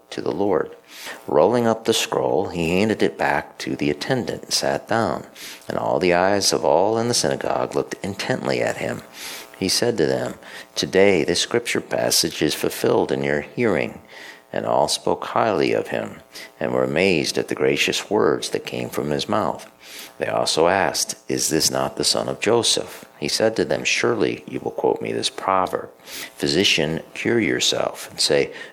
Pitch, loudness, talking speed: 75 Hz, -21 LUFS, 180 wpm